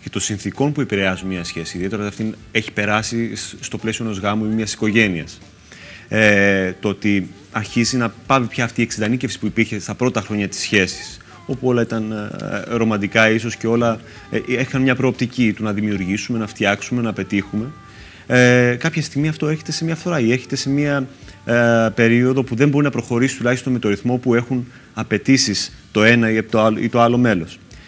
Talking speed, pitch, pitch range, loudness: 185 wpm, 110 Hz, 105-125 Hz, -18 LUFS